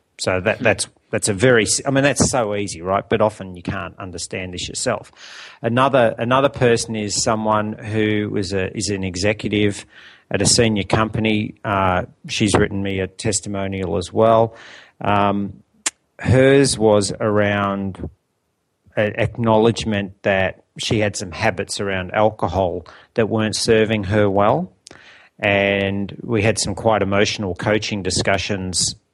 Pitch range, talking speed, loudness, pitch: 100-110 Hz, 140 wpm, -19 LUFS, 105 Hz